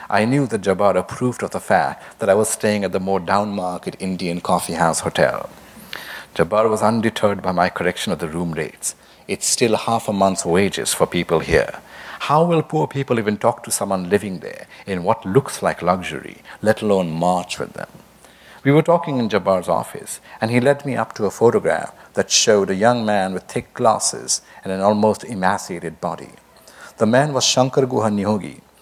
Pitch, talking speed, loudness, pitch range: 105 Hz, 190 wpm, -19 LUFS, 95-120 Hz